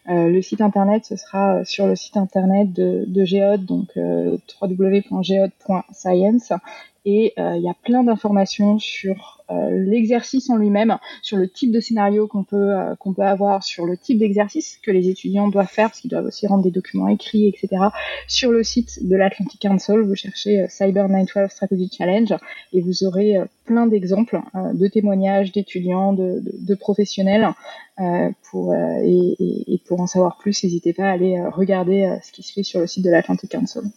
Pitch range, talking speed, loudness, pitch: 185-210 Hz, 195 wpm, -19 LUFS, 195 Hz